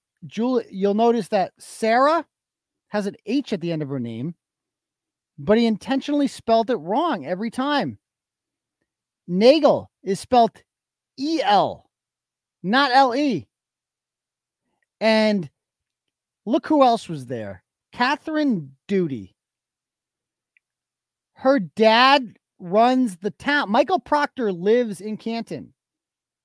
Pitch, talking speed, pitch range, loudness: 220 Hz, 105 wpm, 175-270 Hz, -21 LUFS